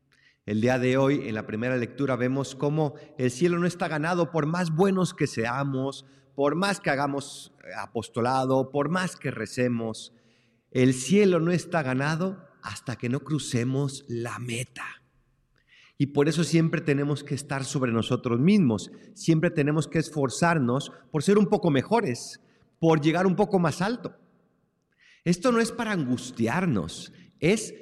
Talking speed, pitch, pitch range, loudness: 155 wpm, 145 Hz, 125-175 Hz, -26 LUFS